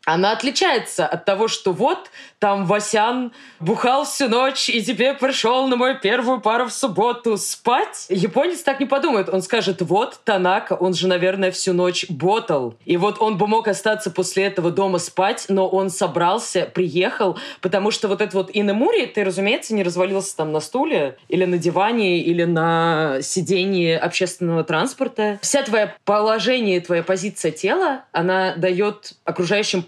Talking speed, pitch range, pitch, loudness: 160 wpm, 185-225 Hz, 200 Hz, -20 LUFS